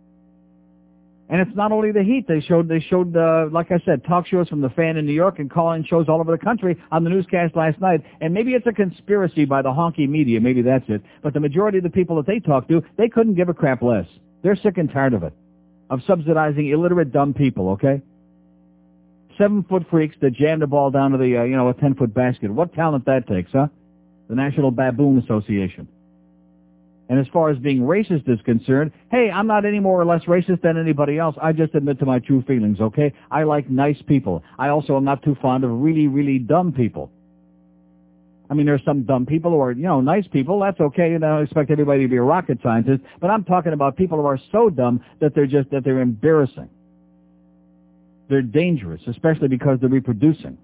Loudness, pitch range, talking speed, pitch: -19 LUFS, 125-165 Hz, 225 wpm, 145 Hz